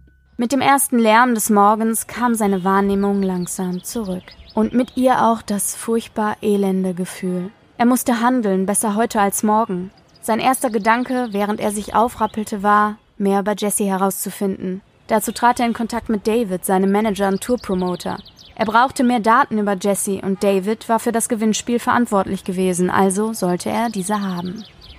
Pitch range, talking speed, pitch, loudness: 195-230 Hz, 165 wpm, 210 Hz, -18 LUFS